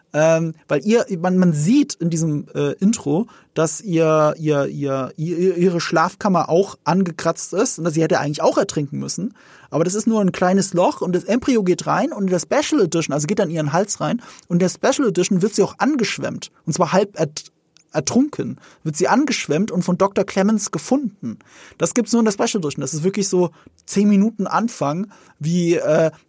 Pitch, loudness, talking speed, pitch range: 180 Hz, -19 LUFS, 205 wpm, 160-205 Hz